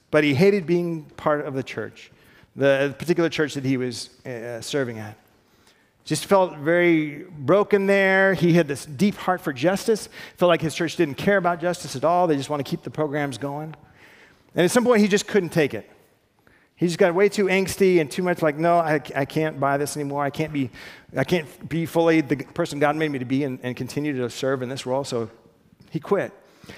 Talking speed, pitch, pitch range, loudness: 215 wpm, 155 Hz, 140-175 Hz, -22 LUFS